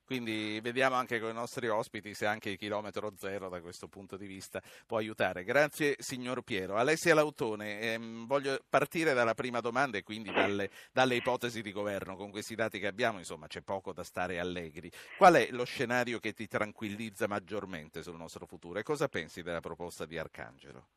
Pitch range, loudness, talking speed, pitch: 100-125 Hz, -33 LUFS, 190 wpm, 110 Hz